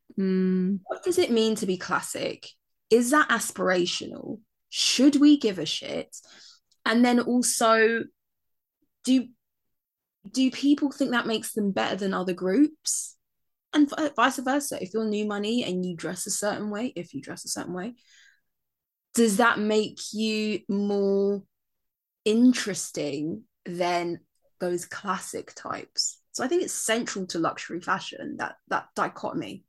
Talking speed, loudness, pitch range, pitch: 140 wpm, -26 LUFS, 190-250 Hz, 220 Hz